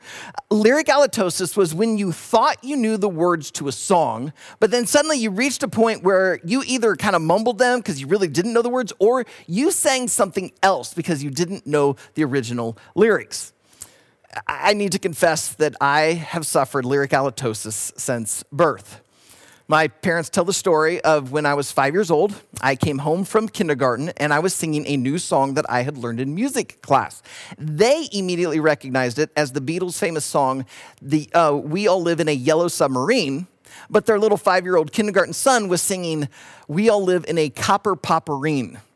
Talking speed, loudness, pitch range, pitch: 190 wpm, -20 LUFS, 145-205 Hz, 170 Hz